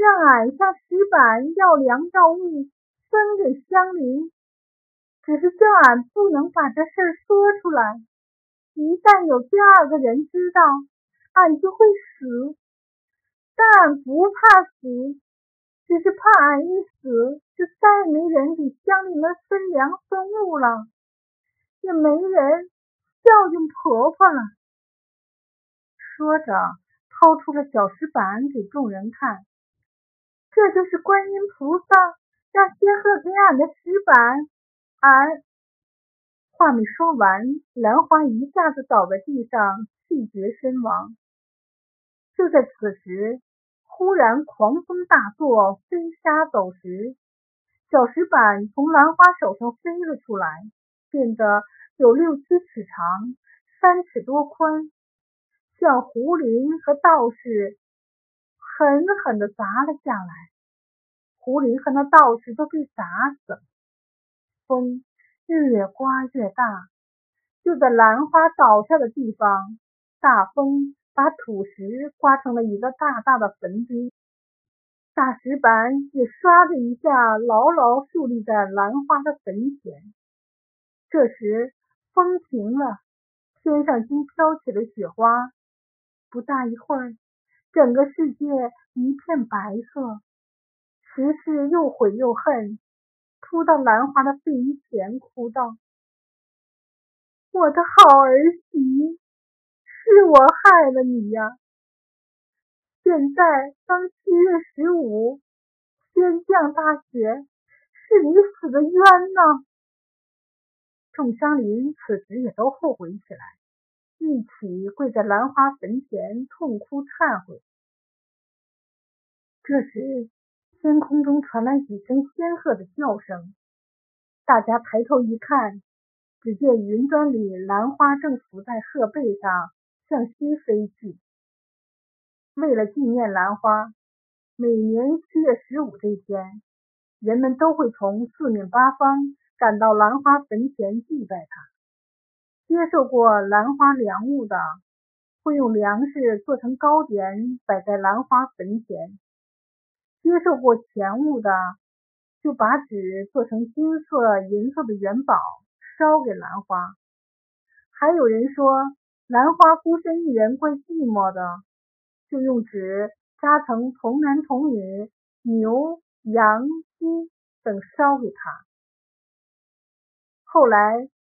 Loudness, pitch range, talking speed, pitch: -19 LUFS, 225-320 Hz, 160 characters per minute, 275 Hz